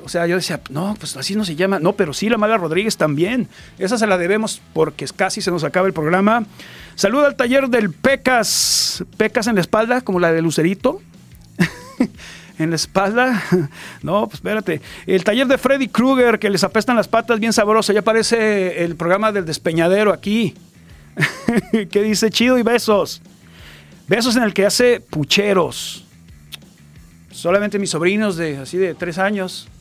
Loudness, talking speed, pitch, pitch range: -17 LUFS, 170 wpm, 195 Hz, 170-220 Hz